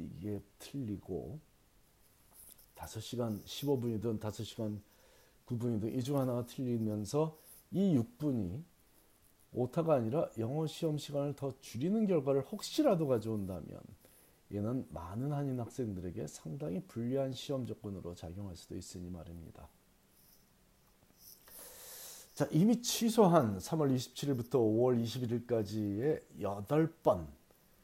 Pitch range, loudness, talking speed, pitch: 105-145 Hz, -36 LUFS, 235 characters per minute, 120 Hz